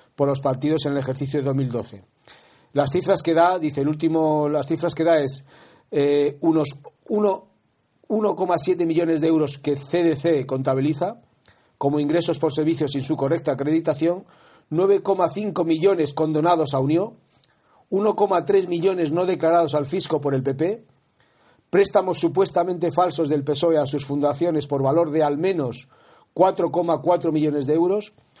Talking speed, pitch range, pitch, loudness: 145 wpm, 145-180 Hz, 160 Hz, -21 LUFS